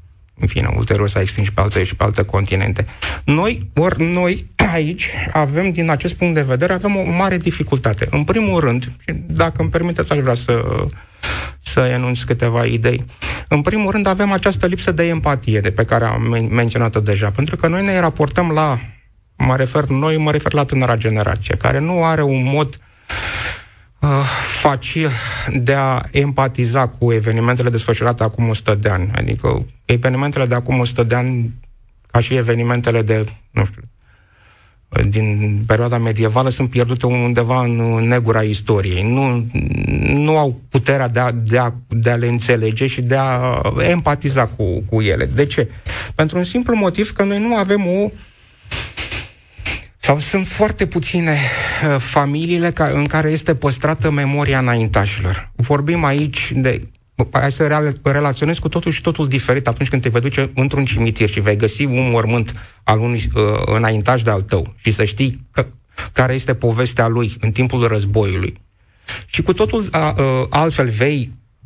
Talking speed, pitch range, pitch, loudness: 165 wpm, 110-145 Hz, 125 Hz, -17 LUFS